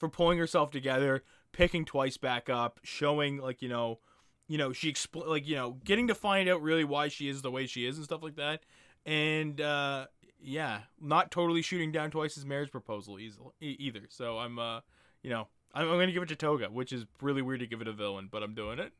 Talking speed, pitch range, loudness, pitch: 225 wpm, 125-155 Hz, -33 LUFS, 140 Hz